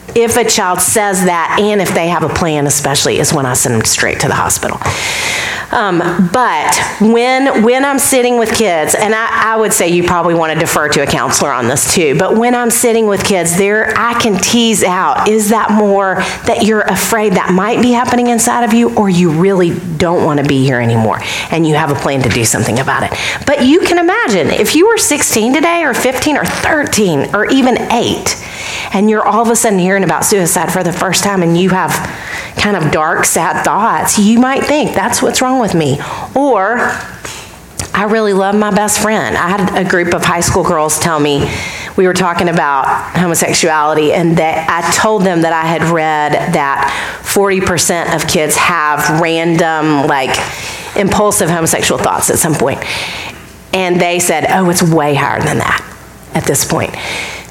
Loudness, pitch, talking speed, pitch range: -11 LUFS, 185 Hz, 200 wpm, 165-220 Hz